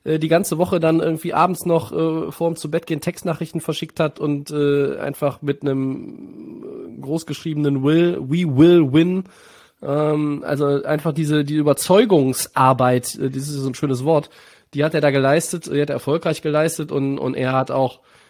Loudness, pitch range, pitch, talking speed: -19 LUFS, 140-165 Hz, 155 Hz, 175 wpm